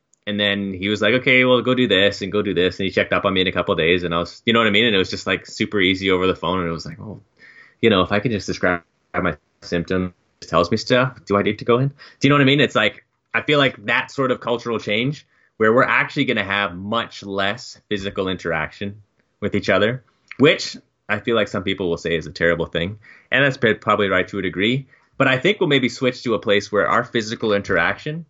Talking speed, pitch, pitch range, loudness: 275 wpm, 105 Hz, 95-125 Hz, -19 LUFS